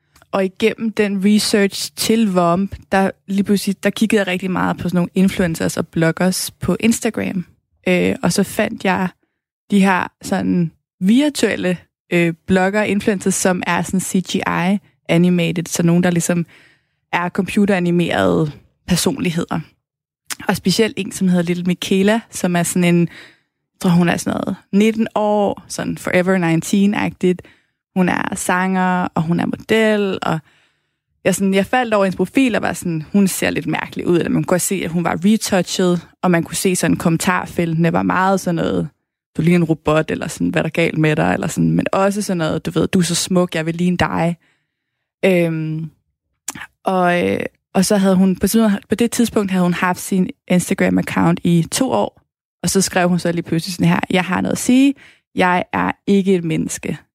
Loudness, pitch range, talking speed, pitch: -17 LUFS, 170-200 Hz, 180 wpm, 180 Hz